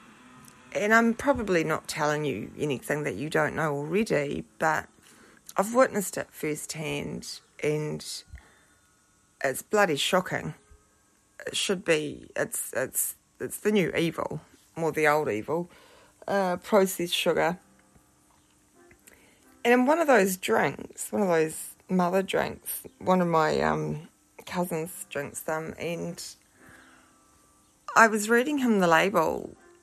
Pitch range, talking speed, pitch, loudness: 145-205 Hz, 125 wpm, 165 Hz, -27 LUFS